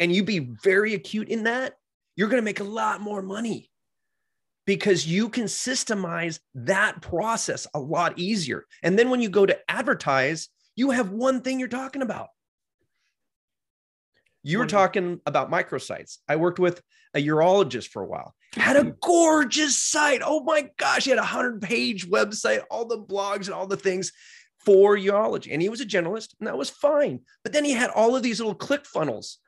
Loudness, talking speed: -24 LUFS, 185 wpm